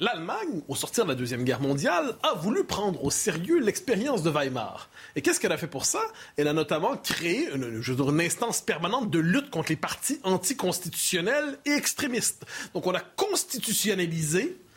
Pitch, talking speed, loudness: 180 Hz, 175 wpm, -27 LUFS